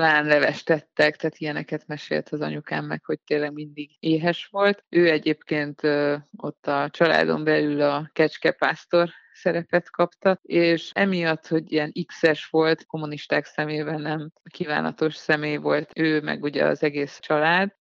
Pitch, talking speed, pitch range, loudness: 155 Hz, 140 wpm, 150-165 Hz, -23 LUFS